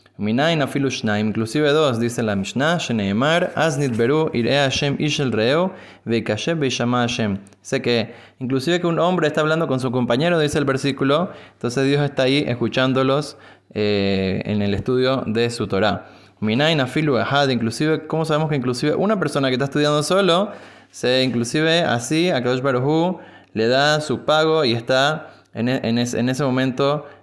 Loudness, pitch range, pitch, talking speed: -20 LUFS, 115-150 Hz, 130 Hz, 155 wpm